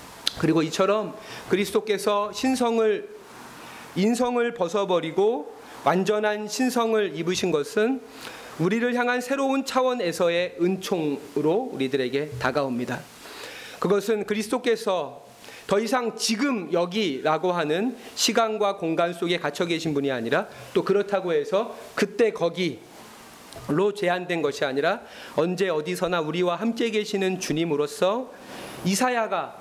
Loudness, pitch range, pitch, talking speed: -25 LUFS, 170-230 Hz, 200 Hz, 285 characters per minute